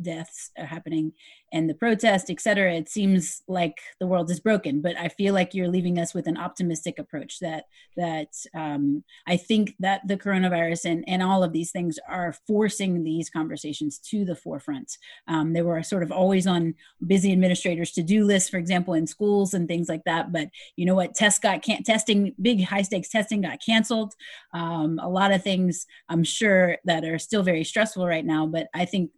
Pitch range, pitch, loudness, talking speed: 165-195 Hz, 180 Hz, -24 LUFS, 200 wpm